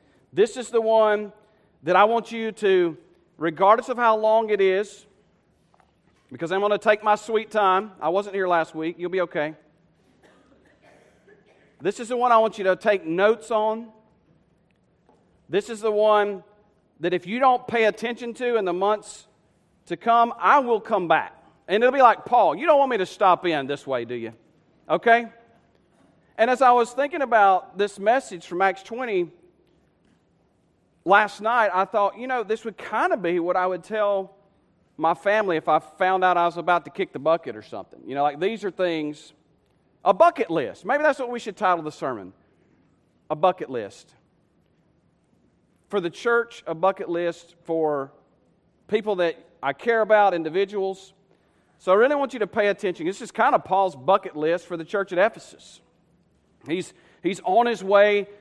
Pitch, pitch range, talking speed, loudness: 200 Hz, 175-225 Hz, 185 wpm, -22 LUFS